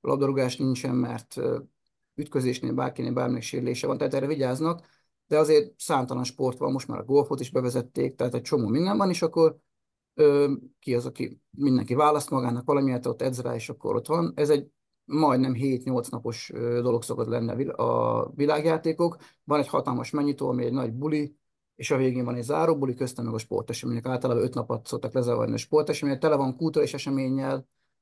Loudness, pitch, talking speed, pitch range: -26 LUFS, 135 Hz, 180 wpm, 125-150 Hz